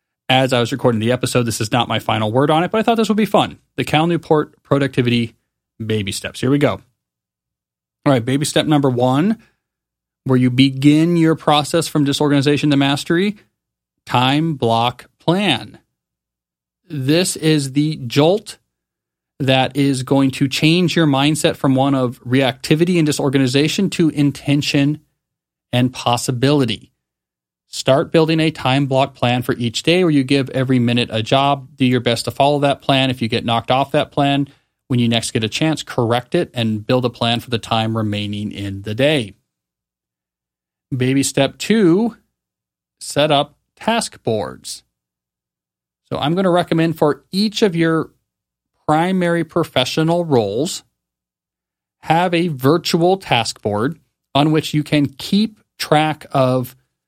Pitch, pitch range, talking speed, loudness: 135 Hz, 115-150 Hz, 155 wpm, -17 LUFS